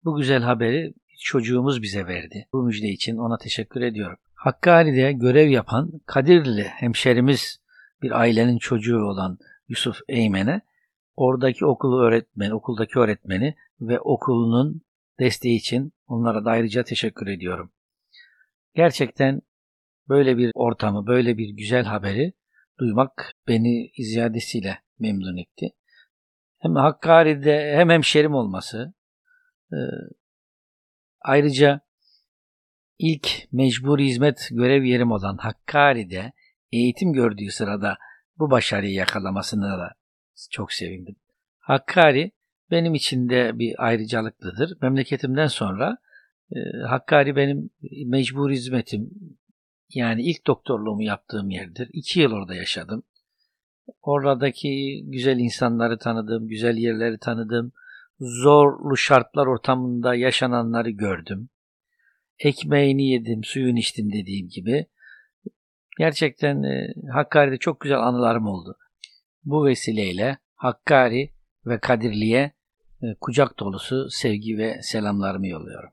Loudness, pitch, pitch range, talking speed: -22 LUFS, 125 Hz, 110-140 Hz, 105 wpm